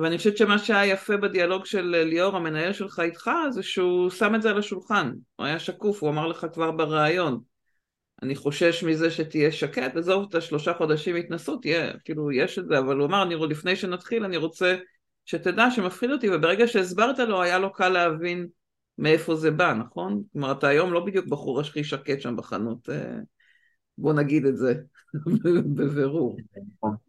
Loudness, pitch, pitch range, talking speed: -25 LUFS, 170 Hz, 150-195 Hz, 175 wpm